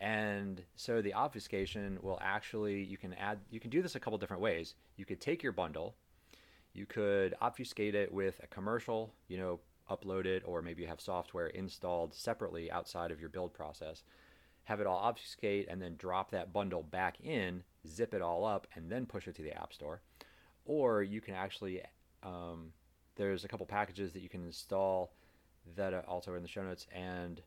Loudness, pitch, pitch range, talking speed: -40 LUFS, 95 Hz, 85-100 Hz, 195 wpm